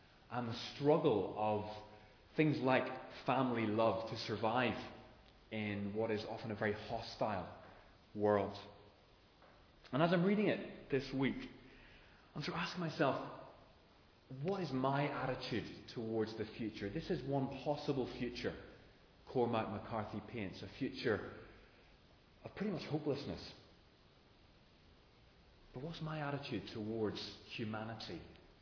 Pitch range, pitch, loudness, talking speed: 105-135 Hz, 115 Hz, -39 LUFS, 120 wpm